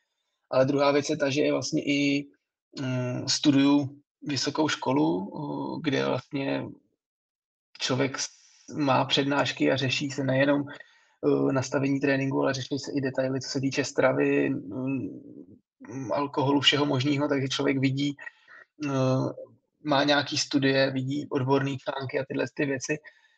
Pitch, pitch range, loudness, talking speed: 140 Hz, 135-145 Hz, -26 LUFS, 125 wpm